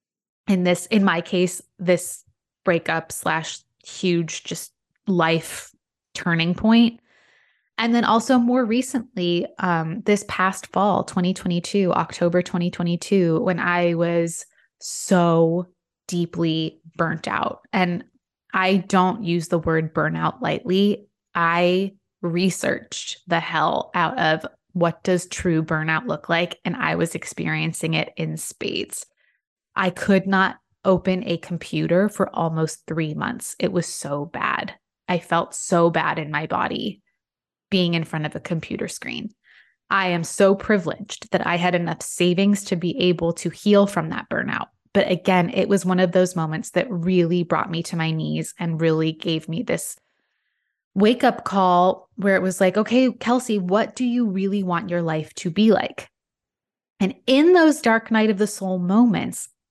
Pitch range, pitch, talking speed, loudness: 170-200 Hz, 180 Hz, 155 wpm, -22 LUFS